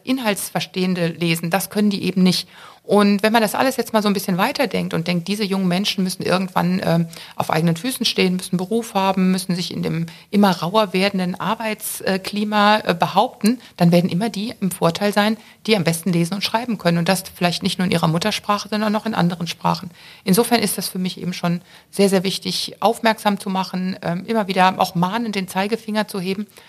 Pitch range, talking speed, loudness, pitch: 180-210 Hz, 205 wpm, -20 LUFS, 195 Hz